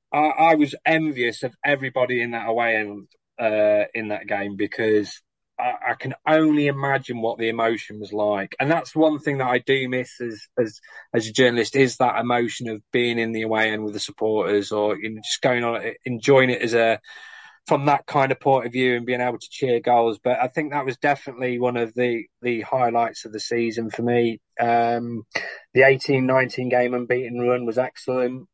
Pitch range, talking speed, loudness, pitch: 115-130 Hz, 205 wpm, -22 LUFS, 120 Hz